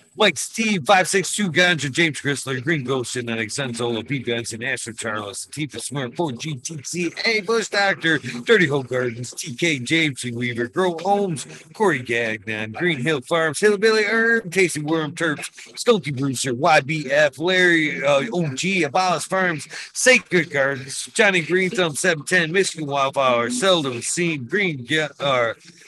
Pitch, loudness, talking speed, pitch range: 155 Hz, -20 LUFS, 140 wpm, 130-180 Hz